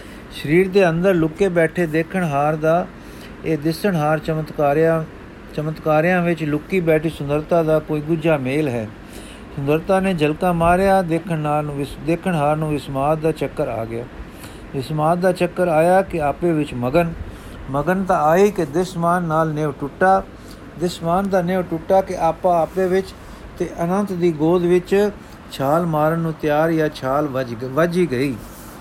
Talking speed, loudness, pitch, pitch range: 155 wpm, -19 LUFS, 160 Hz, 150-180 Hz